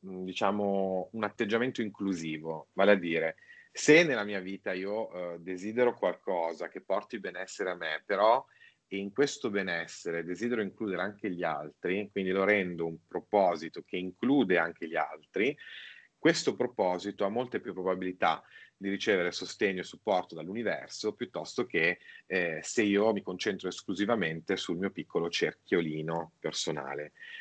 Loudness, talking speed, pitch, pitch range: -31 LUFS, 140 wpm, 95 Hz, 90-105 Hz